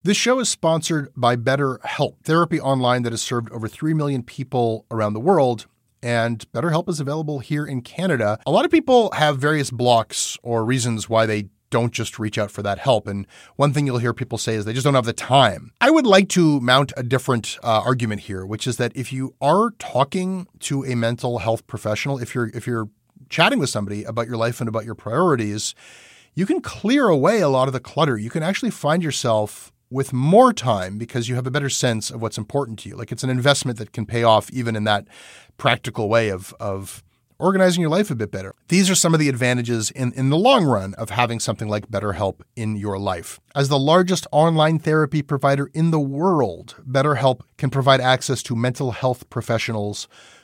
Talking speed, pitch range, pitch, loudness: 210 wpm, 115-145 Hz, 125 Hz, -20 LUFS